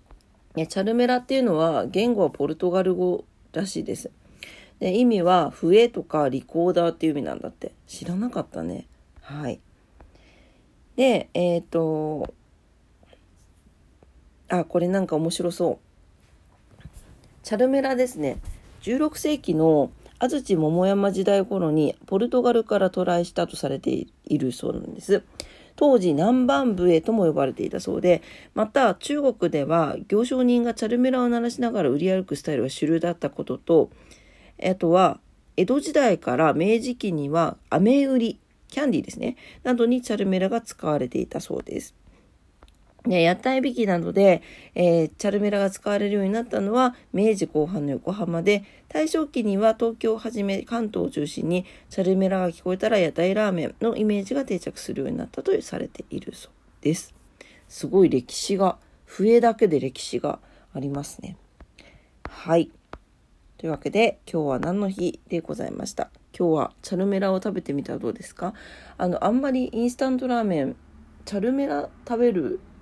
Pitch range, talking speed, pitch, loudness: 165-235 Hz, 320 characters per minute, 195 Hz, -23 LUFS